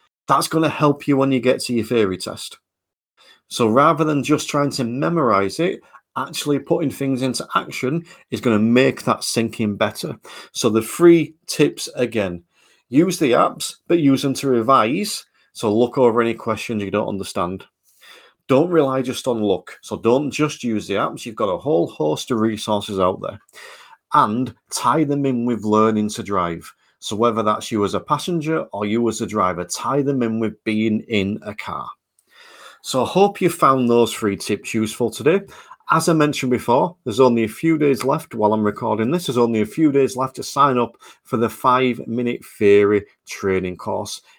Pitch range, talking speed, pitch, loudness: 105-140 Hz, 190 wpm, 120 Hz, -19 LUFS